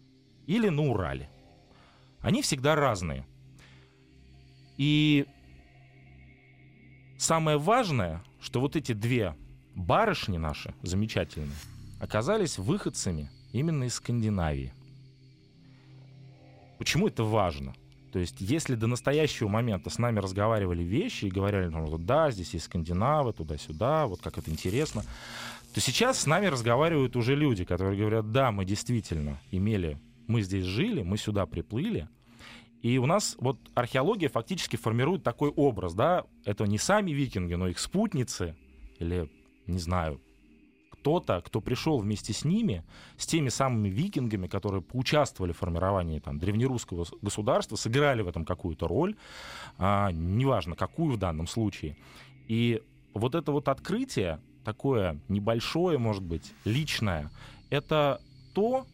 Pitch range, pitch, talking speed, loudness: 90-135 Hz, 110 Hz, 125 wpm, -29 LUFS